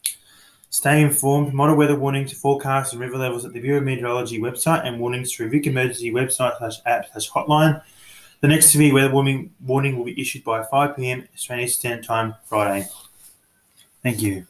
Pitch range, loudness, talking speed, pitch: 120-140 Hz, -20 LUFS, 165 wpm, 130 Hz